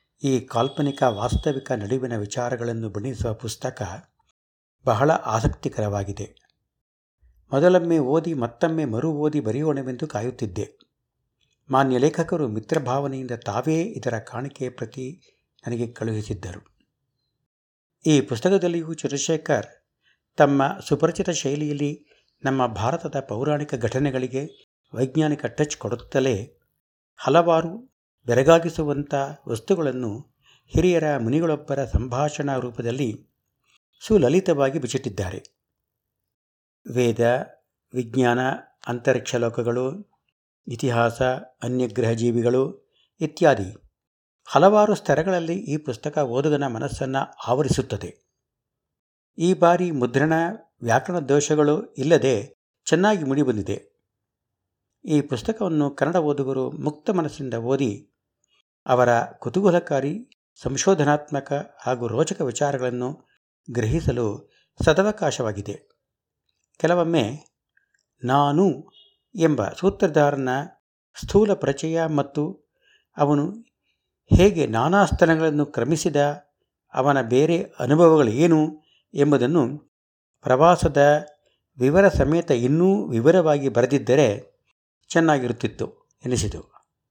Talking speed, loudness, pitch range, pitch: 75 wpm, -22 LUFS, 120-160 Hz, 140 Hz